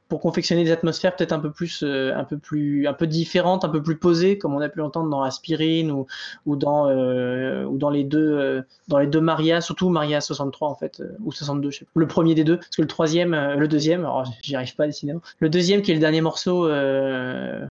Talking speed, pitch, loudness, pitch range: 255 wpm, 155 Hz, -22 LUFS, 140-165 Hz